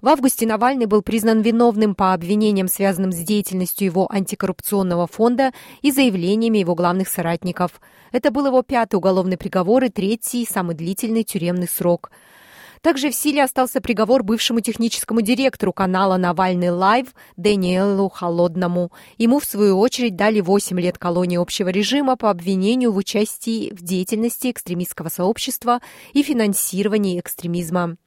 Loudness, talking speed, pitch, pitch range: -19 LUFS, 140 wpm, 205 Hz, 185-235 Hz